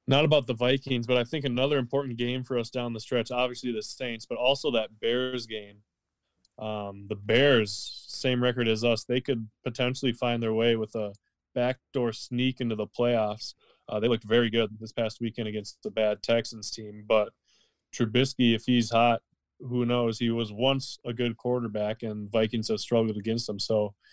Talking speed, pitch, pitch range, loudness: 190 wpm, 115 Hz, 110-125 Hz, -28 LUFS